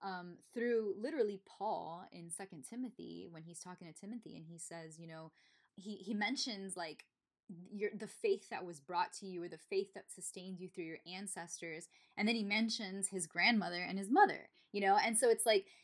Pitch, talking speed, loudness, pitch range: 195 Hz, 200 wpm, -38 LUFS, 175-220 Hz